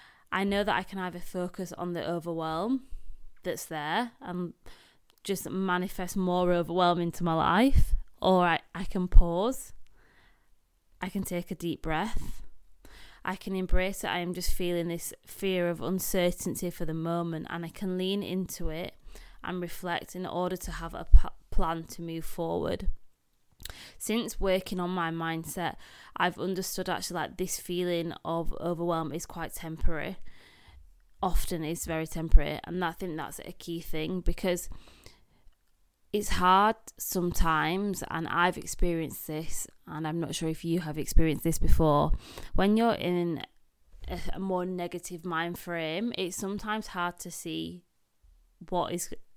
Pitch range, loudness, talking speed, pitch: 165-185 Hz, -31 LUFS, 150 wpm, 175 Hz